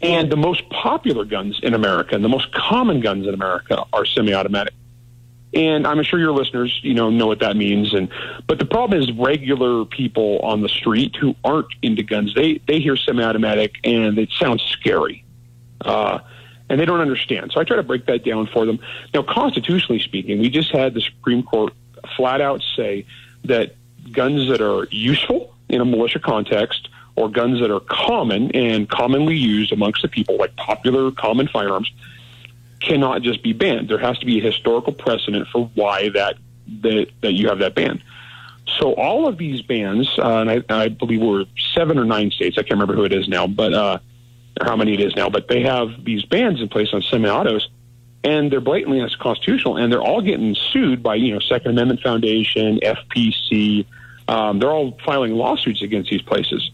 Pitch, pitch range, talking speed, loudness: 120 Hz, 110-130 Hz, 190 wpm, -18 LUFS